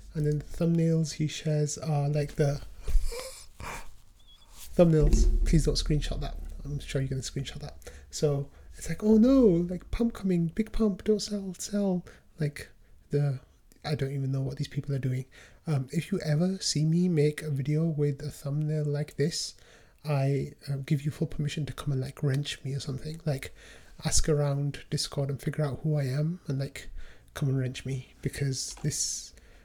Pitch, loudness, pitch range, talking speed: 150 Hz, -29 LUFS, 140-165 Hz, 185 wpm